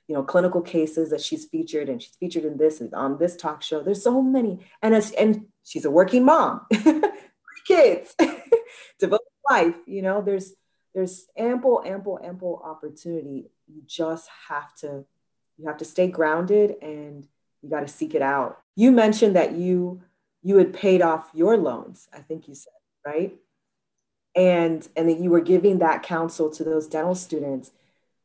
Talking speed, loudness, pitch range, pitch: 175 wpm, -22 LUFS, 155-210 Hz, 180 Hz